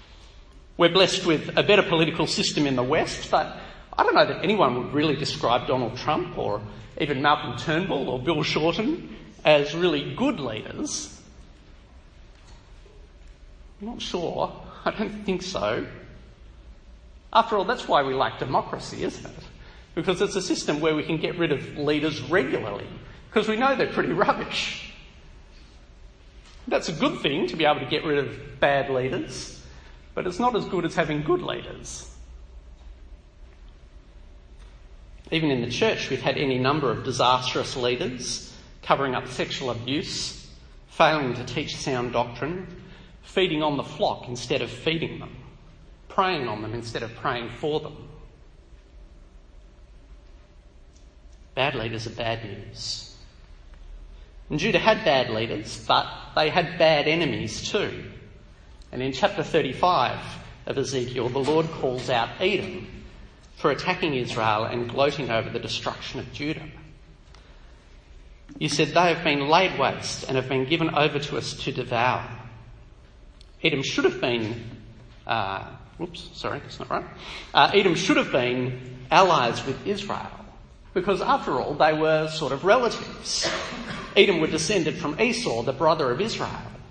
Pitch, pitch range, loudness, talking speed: 125 Hz, 95-155 Hz, -24 LUFS, 145 wpm